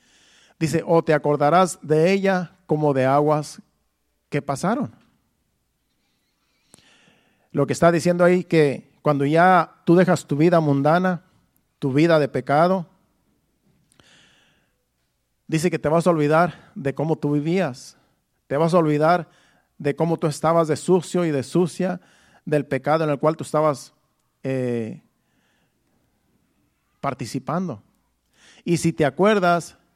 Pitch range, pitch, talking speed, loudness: 145-175 Hz, 155 Hz, 130 wpm, -21 LUFS